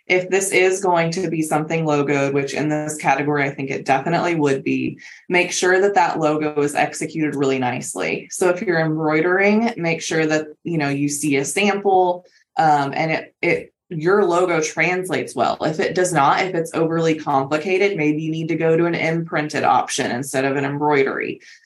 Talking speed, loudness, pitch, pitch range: 190 wpm, -19 LUFS, 160 Hz, 150-180 Hz